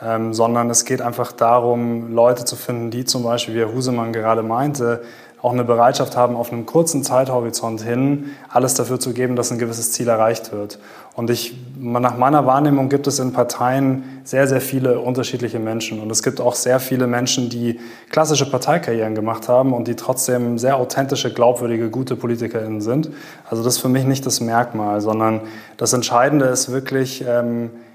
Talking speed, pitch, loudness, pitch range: 180 wpm, 120 Hz, -18 LUFS, 115-130 Hz